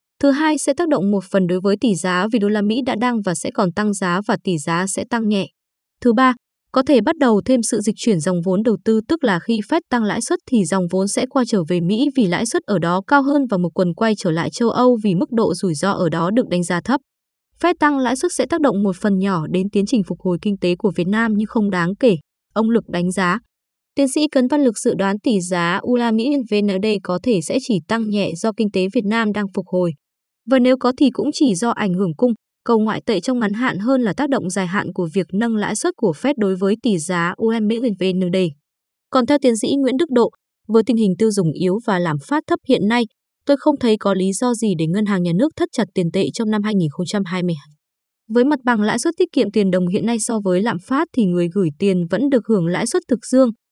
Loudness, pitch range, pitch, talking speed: -18 LUFS, 185-250 Hz, 215 Hz, 265 wpm